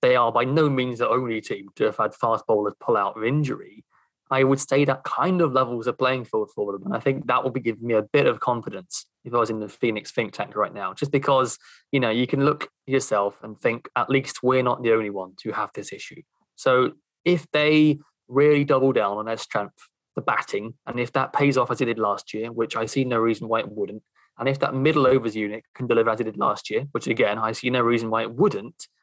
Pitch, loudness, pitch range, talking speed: 125 Hz, -23 LUFS, 115-135 Hz, 255 wpm